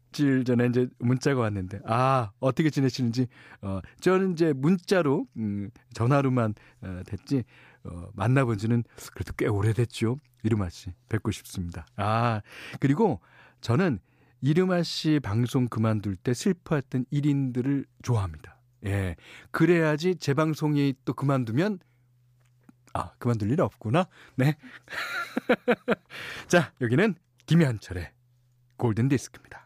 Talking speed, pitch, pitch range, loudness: 265 characters per minute, 125 Hz, 115-150 Hz, -27 LUFS